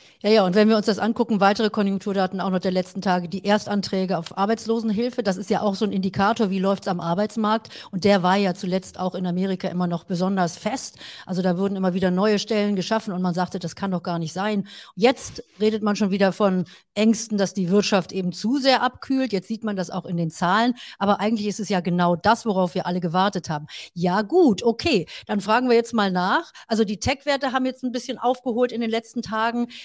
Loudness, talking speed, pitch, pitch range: -23 LUFS, 230 wpm, 200 Hz, 185-225 Hz